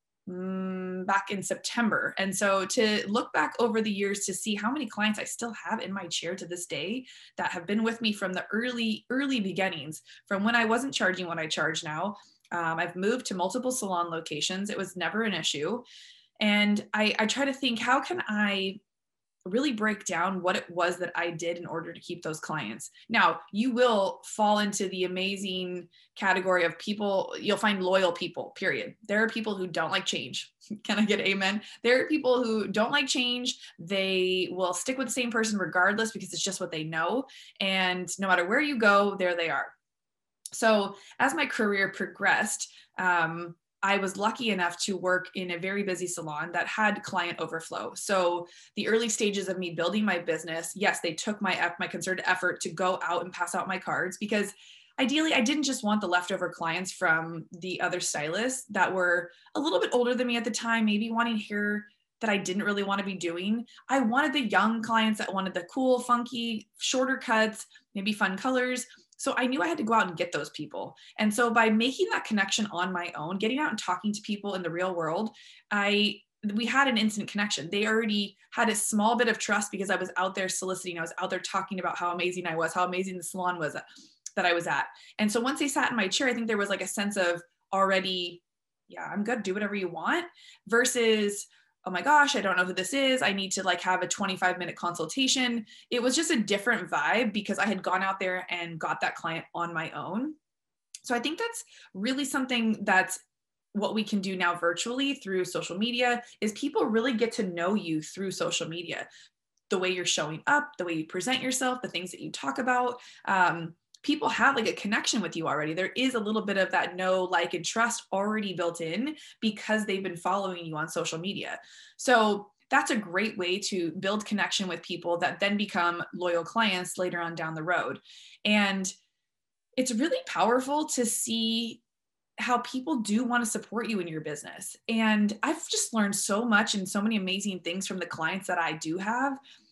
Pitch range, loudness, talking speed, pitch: 180-230 Hz, -28 LUFS, 210 wpm, 200 Hz